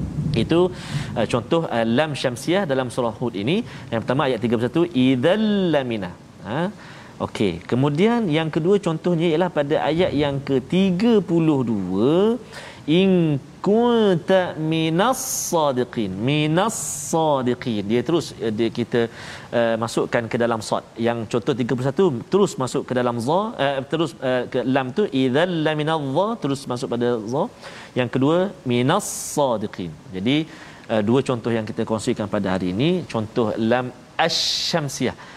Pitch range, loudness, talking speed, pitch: 120-165 Hz, -21 LUFS, 135 wpm, 135 Hz